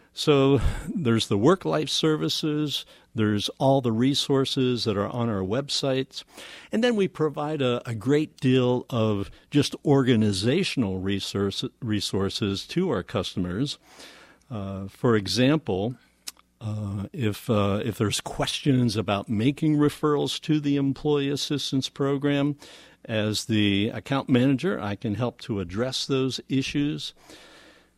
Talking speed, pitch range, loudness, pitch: 125 wpm, 105-145 Hz, -25 LUFS, 130 Hz